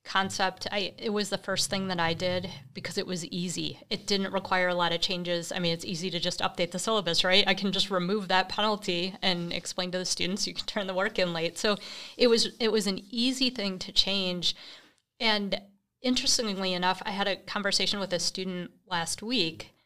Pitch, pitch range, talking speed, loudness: 190 Hz, 180-200 Hz, 215 wpm, -28 LUFS